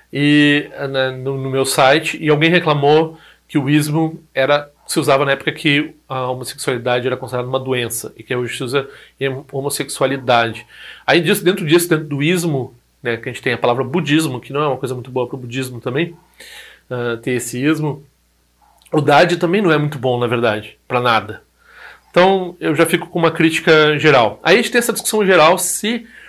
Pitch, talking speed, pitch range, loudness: 145 Hz, 200 wpm, 130-165 Hz, -16 LUFS